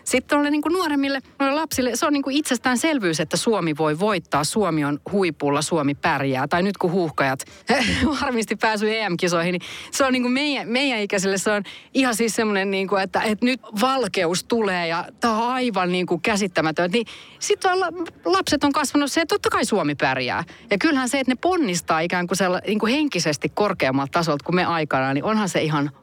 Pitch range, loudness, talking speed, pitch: 175-265 Hz, -21 LUFS, 185 wpm, 215 Hz